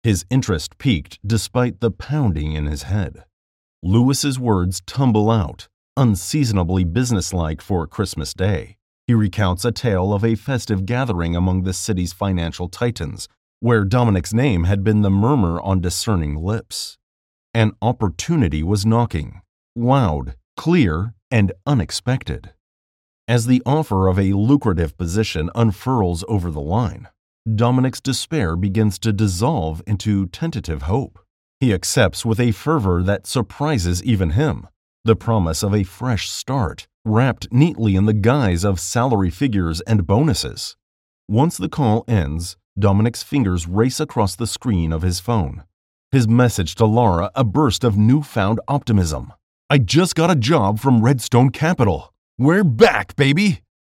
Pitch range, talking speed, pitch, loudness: 90-120 Hz, 140 wpm, 105 Hz, -19 LUFS